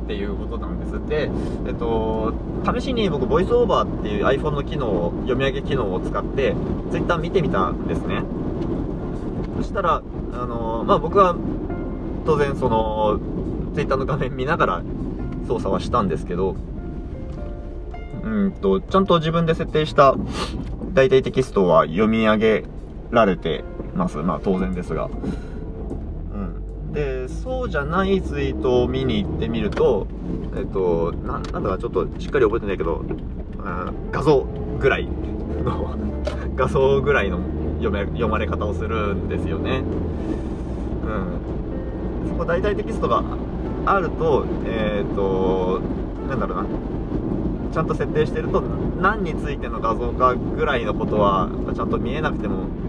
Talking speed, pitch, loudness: 300 characters per minute, 90 Hz, -22 LUFS